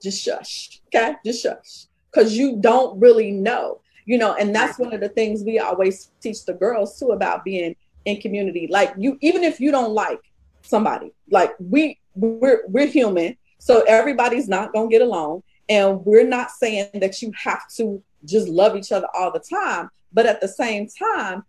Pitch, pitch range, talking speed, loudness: 225 Hz, 200-255 Hz, 185 wpm, -19 LUFS